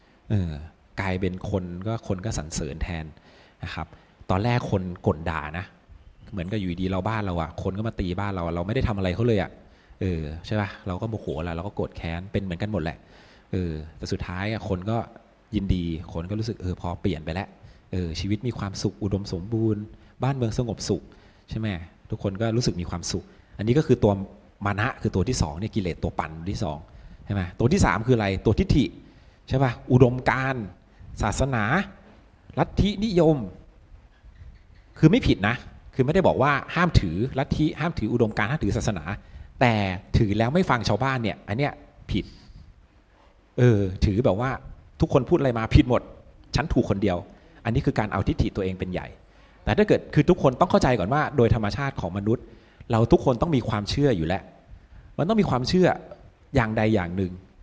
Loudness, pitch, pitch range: -25 LUFS, 100 Hz, 90-115 Hz